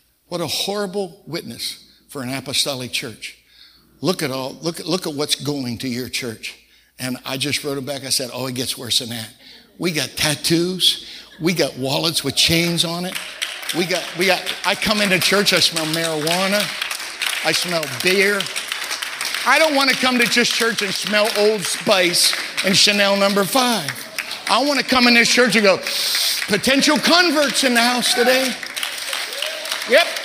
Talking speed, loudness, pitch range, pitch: 180 wpm, -18 LUFS, 145-215 Hz, 180 Hz